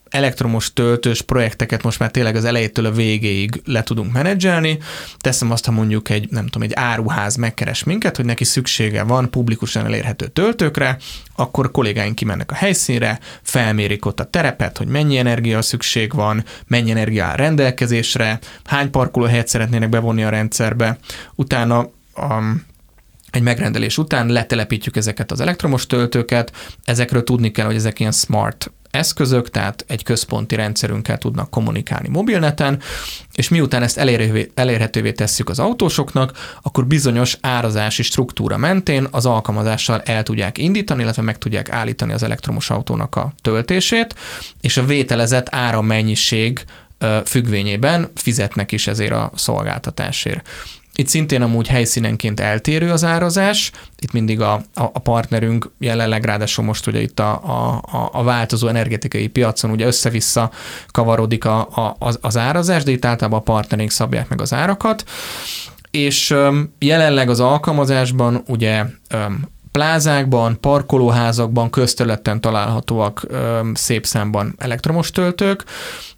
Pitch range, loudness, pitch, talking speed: 110-140 Hz, -17 LUFS, 120 Hz, 135 wpm